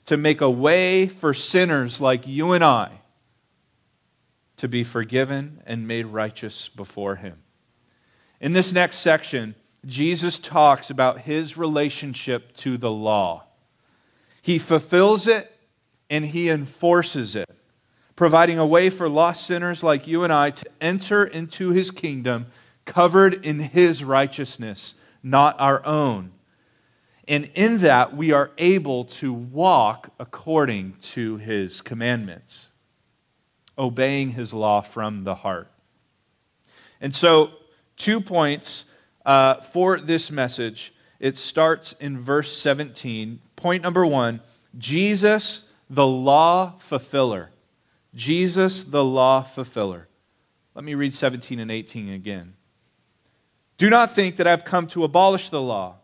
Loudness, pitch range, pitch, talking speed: -21 LUFS, 120-170 Hz, 145 Hz, 125 wpm